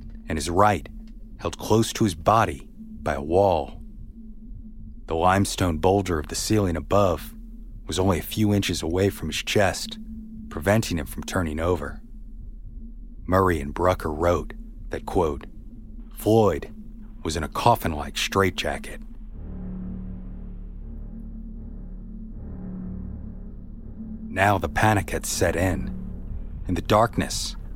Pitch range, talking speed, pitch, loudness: 85-110 Hz, 115 wpm, 95 Hz, -24 LUFS